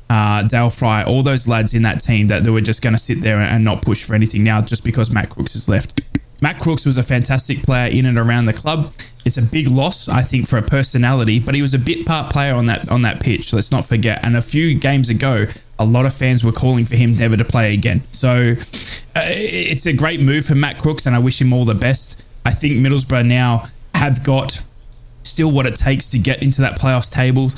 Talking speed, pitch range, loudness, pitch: 245 wpm, 115-135 Hz, -16 LUFS, 125 Hz